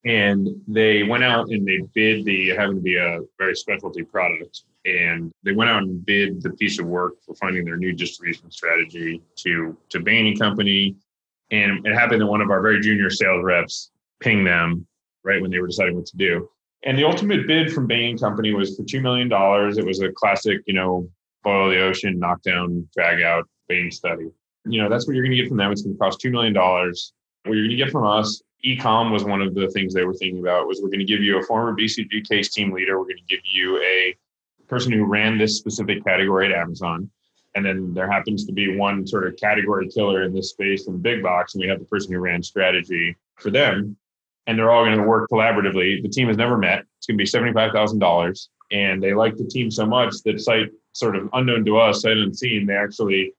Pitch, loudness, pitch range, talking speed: 100 Hz, -20 LUFS, 95-110 Hz, 235 wpm